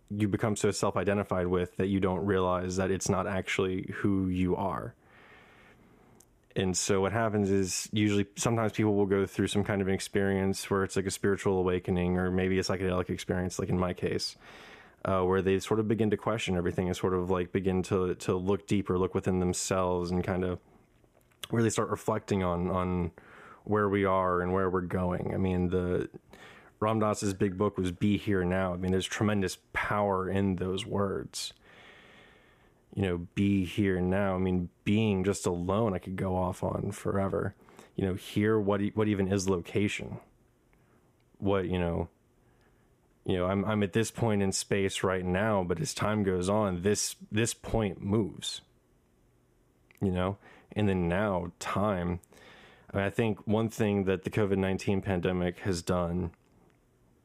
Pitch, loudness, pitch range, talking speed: 95 Hz, -30 LUFS, 90-105 Hz, 175 wpm